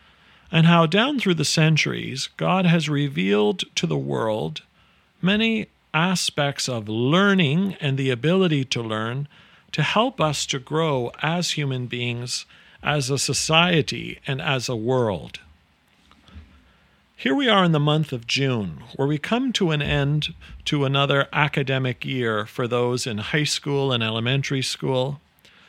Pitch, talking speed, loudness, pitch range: 145 Hz, 145 wpm, -22 LUFS, 130-170 Hz